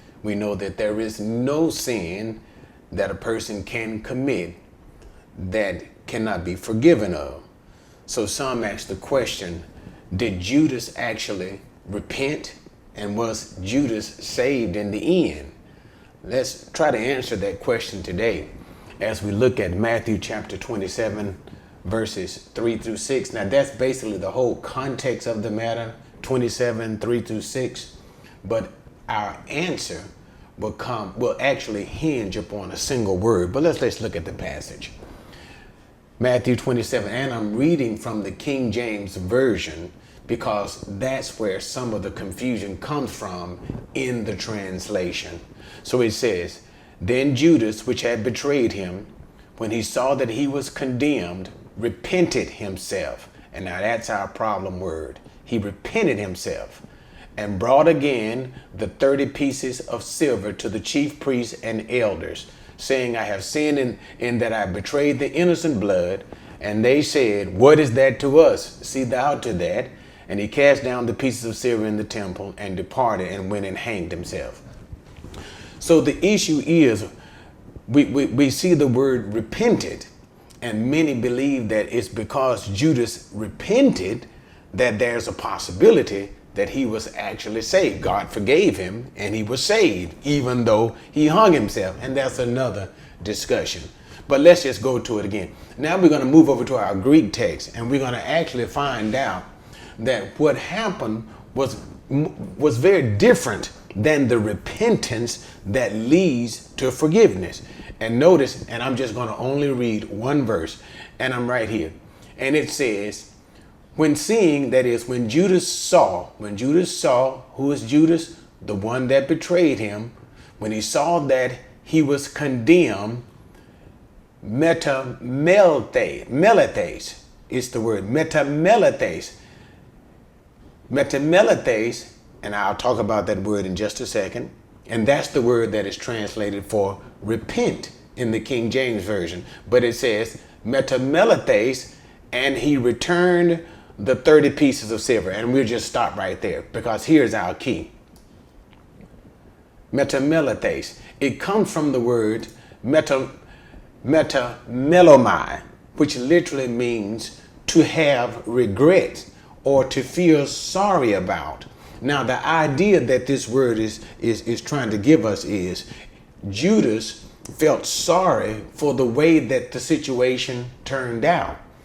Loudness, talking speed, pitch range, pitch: -21 LUFS, 145 wpm, 105-140 Hz, 120 Hz